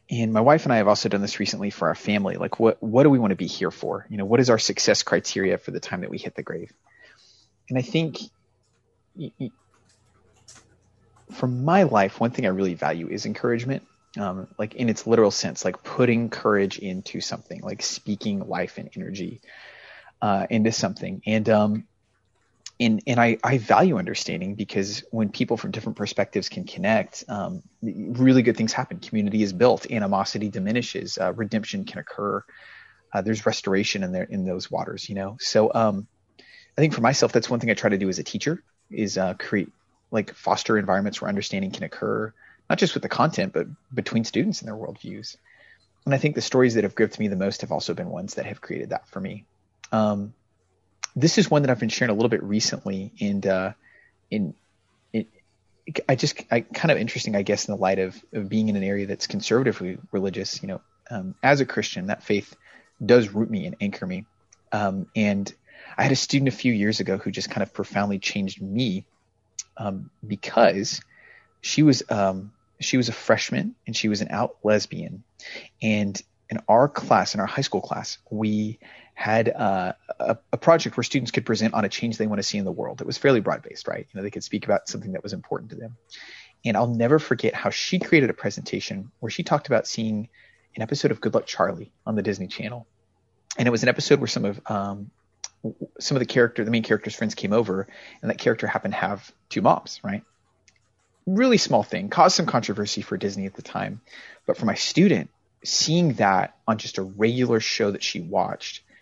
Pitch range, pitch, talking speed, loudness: 100-125 Hz, 110 Hz, 205 wpm, -24 LUFS